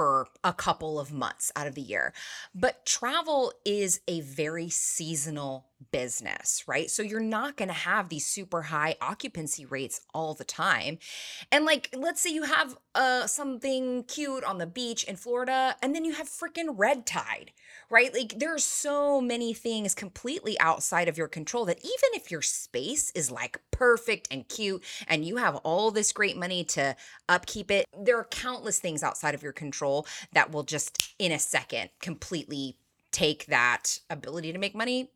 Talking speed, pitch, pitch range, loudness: 175 wpm, 200 Hz, 155-255 Hz, -29 LUFS